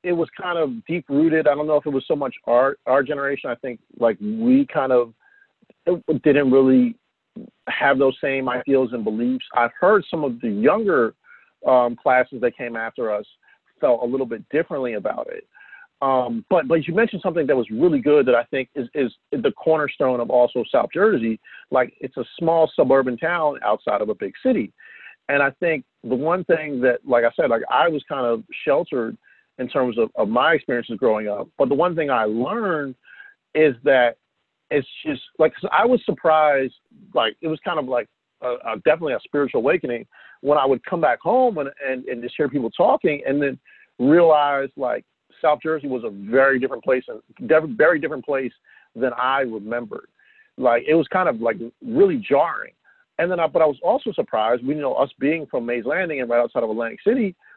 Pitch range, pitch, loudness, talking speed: 125-185 Hz, 145 Hz, -21 LUFS, 200 wpm